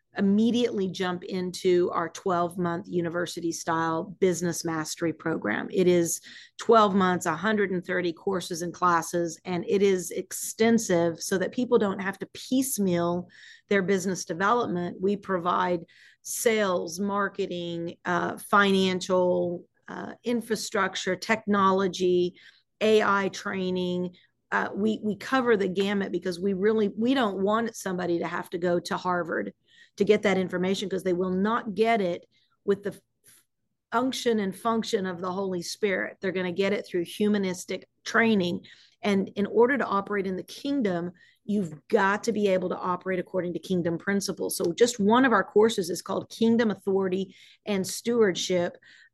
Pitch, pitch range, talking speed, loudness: 190 Hz, 180-210 Hz, 145 wpm, -26 LUFS